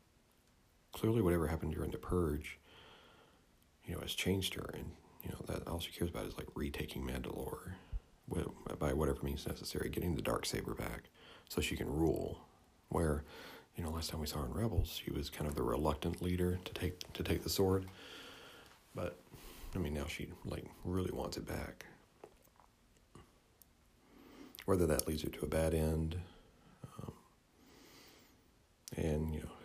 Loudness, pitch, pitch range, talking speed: -39 LUFS, 85 Hz, 75-90 Hz, 165 wpm